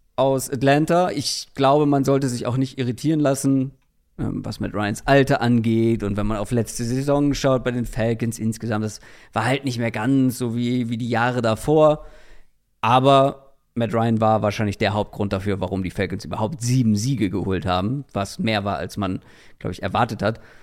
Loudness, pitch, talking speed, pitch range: -21 LUFS, 120 Hz, 185 wpm, 105-135 Hz